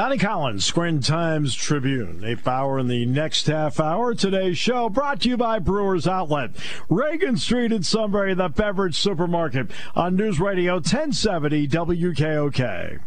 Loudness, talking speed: -22 LUFS, 145 wpm